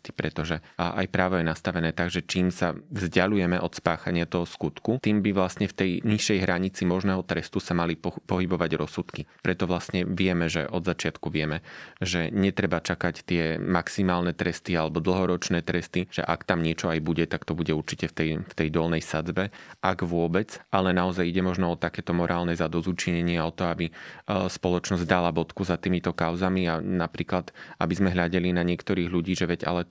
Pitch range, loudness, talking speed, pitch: 85-95 Hz, -27 LUFS, 180 wpm, 90 Hz